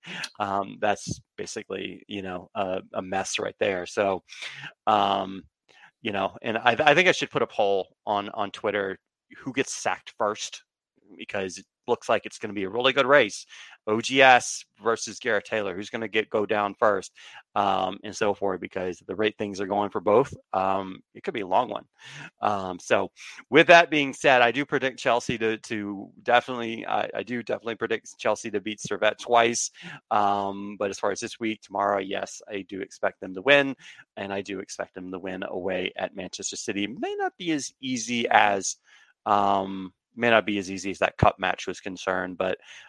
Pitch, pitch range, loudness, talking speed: 105 Hz, 95-120 Hz, -25 LUFS, 195 wpm